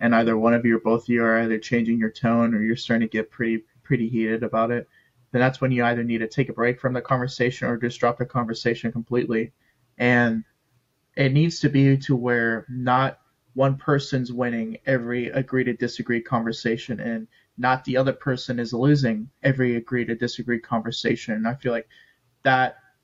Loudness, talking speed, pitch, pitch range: -23 LUFS, 200 wpm, 120 Hz, 115-130 Hz